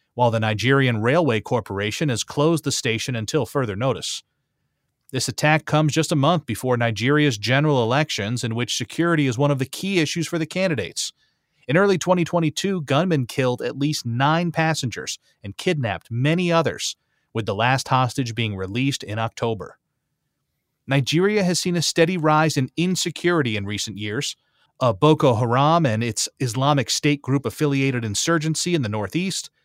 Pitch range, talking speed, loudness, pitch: 120-160 Hz, 160 wpm, -21 LUFS, 140 Hz